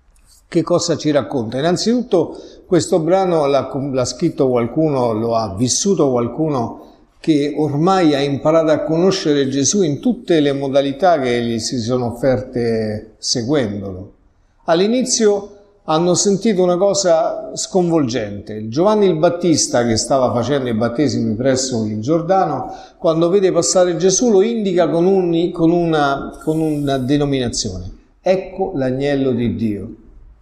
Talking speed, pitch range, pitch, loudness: 130 wpm, 120-175 Hz, 145 Hz, -16 LUFS